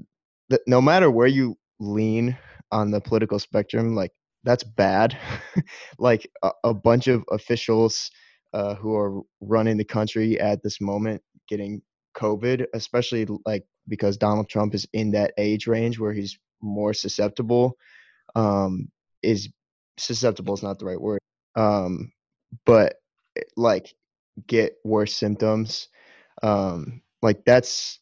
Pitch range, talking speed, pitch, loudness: 105-115 Hz, 130 wpm, 110 Hz, -23 LUFS